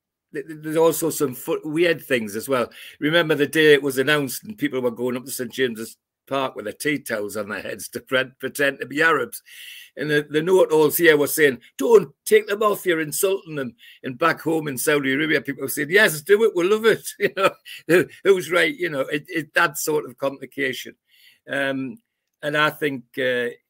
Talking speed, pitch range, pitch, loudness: 210 wpm, 135-170 Hz, 150 Hz, -21 LUFS